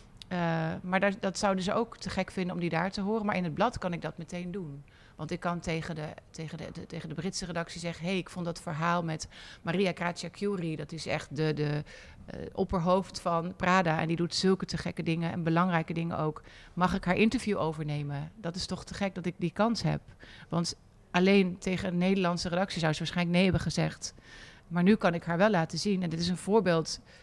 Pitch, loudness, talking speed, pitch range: 175 Hz, -31 LUFS, 235 wpm, 165-190 Hz